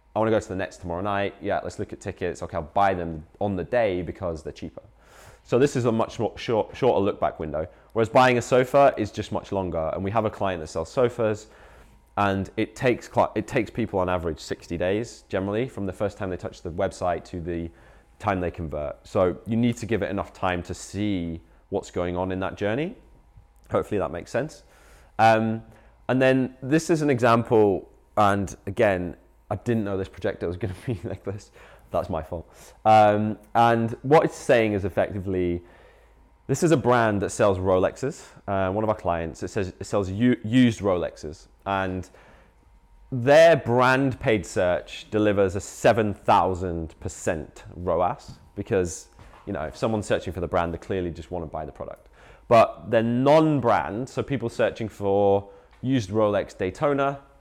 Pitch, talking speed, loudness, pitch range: 100 Hz, 190 wpm, -24 LUFS, 90-115 Hz